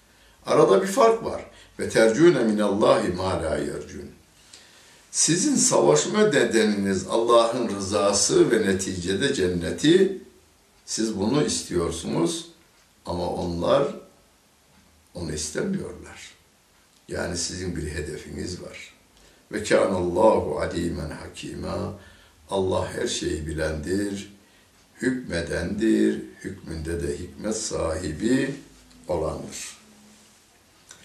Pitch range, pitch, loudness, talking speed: 85-110 Hz, 95 Hz, -23 LUFS, 80 wpm